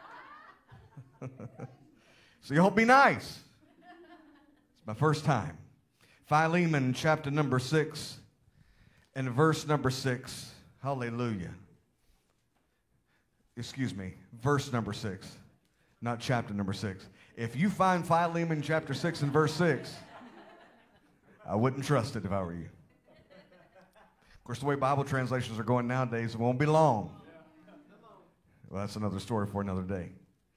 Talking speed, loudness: 125 wpm, -30 LUFS